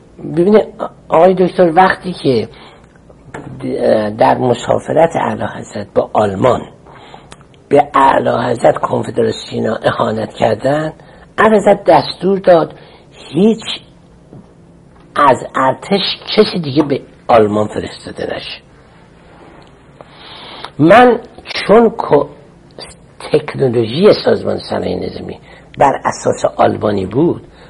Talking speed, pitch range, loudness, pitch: 85 wpm, 150-205 Hz, -13 LUFS, 180 Hz